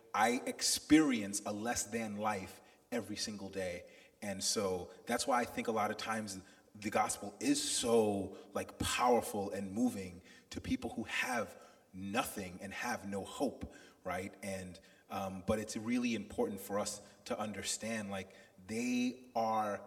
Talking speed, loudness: 150 wpm, -37 LUFS